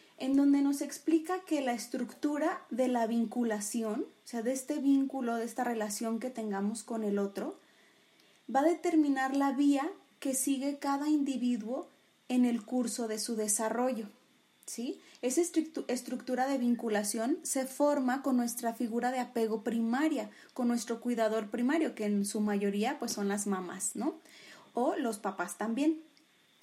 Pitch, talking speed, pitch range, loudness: 250 Hz, 155 wpm, 225-280 Hz, -32 LUFS